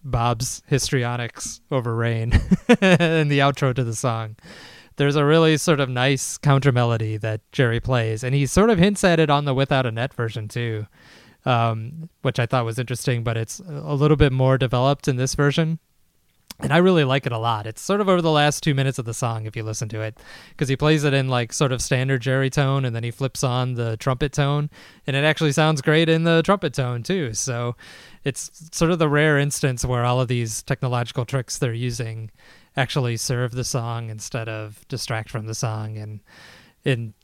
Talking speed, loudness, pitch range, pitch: 210 wpm, -21 LUFS, 115-145 Hz, 130 Hz